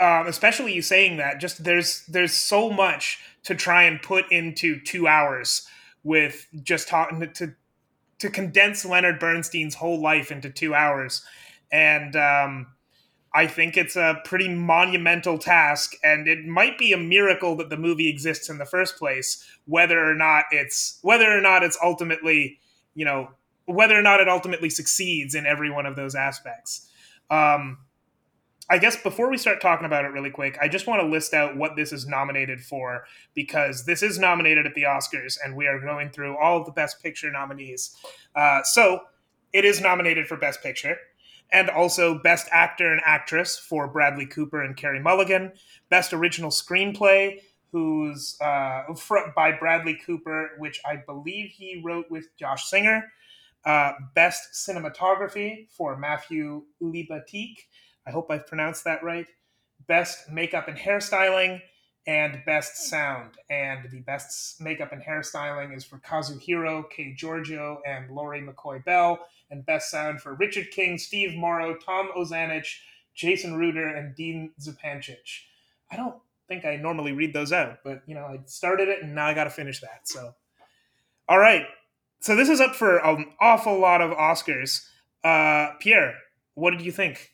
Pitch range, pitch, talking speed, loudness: 145-180 Hz, 160 Hz, 165 wpm, -21 LUFS